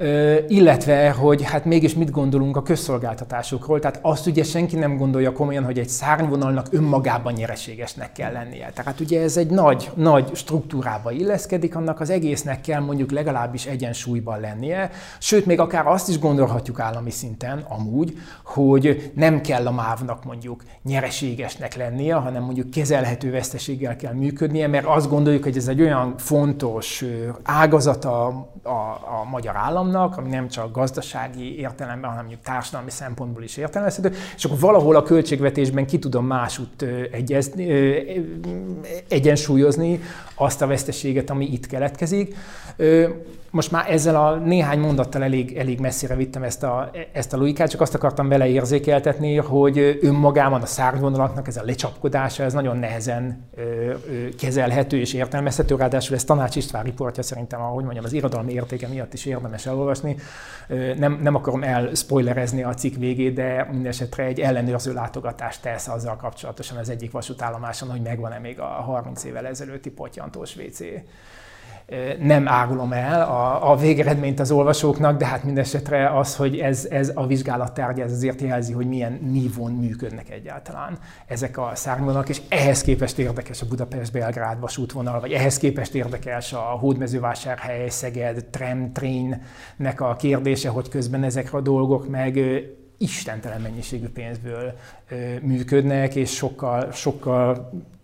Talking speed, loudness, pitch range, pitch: 145 wpm, -22 LUFS, 125-145 Hz, 135 Hz